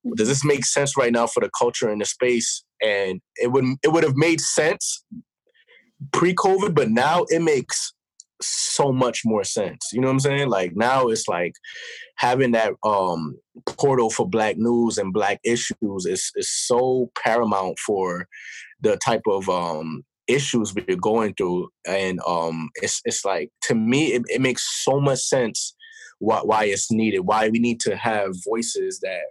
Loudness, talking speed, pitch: -22 LUFS, 175 wpm, 135 Hz